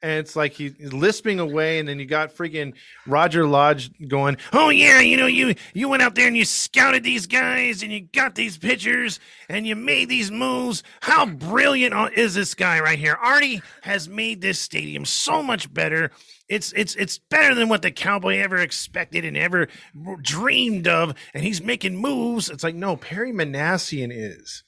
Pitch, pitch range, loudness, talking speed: 200 Hz, 155-240 Hz, -19 LUFS, 190 wpm